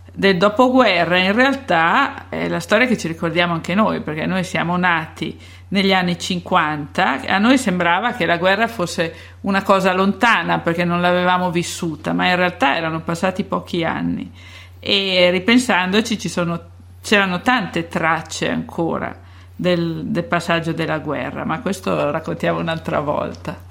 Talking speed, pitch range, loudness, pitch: 150 wpm, 165-195 Hz, -18 LUFS, 180 Hz